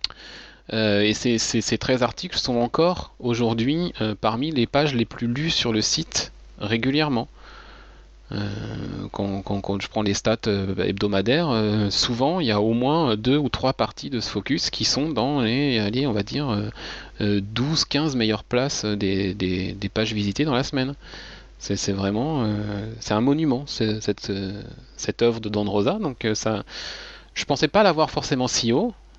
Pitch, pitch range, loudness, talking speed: 110 Hz, 105-130 Hz, -23 LUFS, 175 wpm